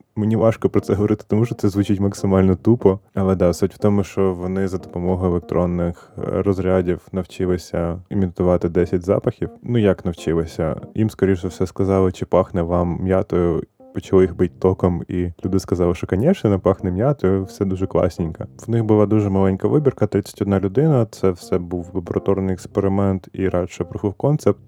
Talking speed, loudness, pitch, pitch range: 170 wpm, -20 LUFS, 95 Hz, 90-105 Hz